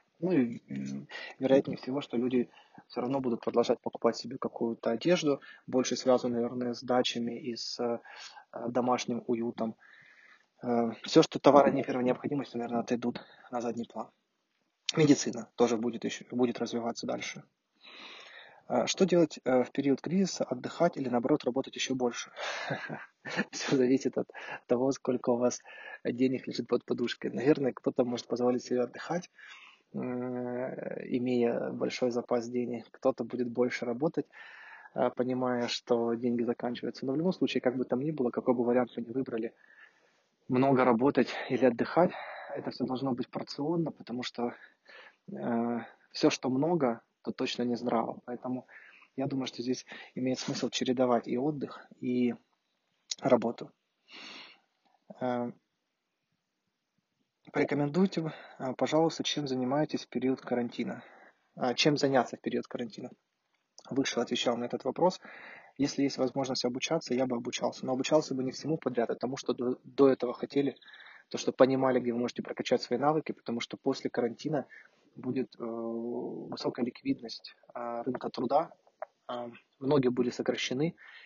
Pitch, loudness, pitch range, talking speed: 125 Hz, -31 LUFS, 120-135 Hz, 140 wpm